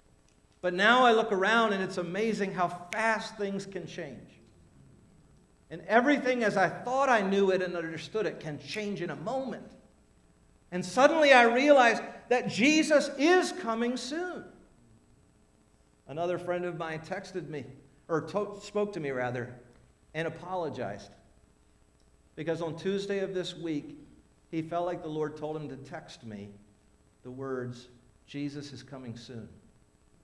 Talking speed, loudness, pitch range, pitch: 145 wpm, -29 LUFS, 130-205 Hz, 170 Hz